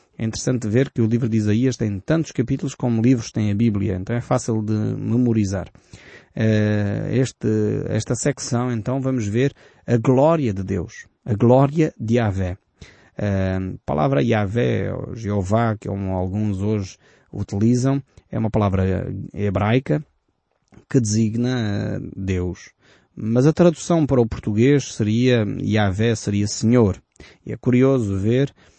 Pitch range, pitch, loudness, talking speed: 100-125 Hz, 115 Hz, -21 LUFS, 135 wpm